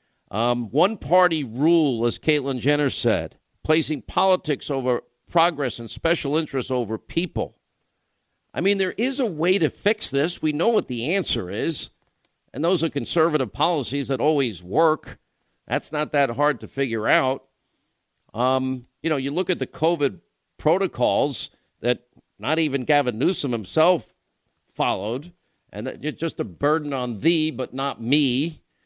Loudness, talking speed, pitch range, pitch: -23 LUFS, 150 wpm, 125-160 Hz, 145 Hz